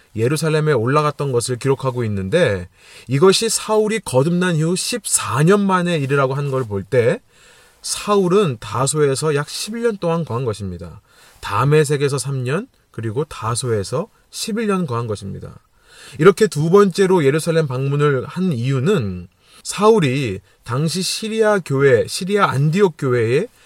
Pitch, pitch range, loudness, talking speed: 145 Hz, 125-185 Hz, -18 LUFS, 290 characters per minute